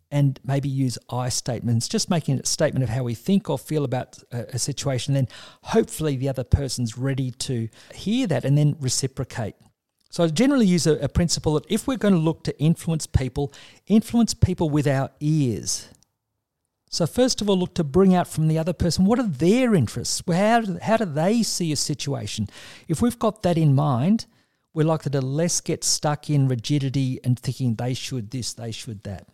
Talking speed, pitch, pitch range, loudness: 200 wpm, 145 Hz, 125-175 Hz, -23 LUFS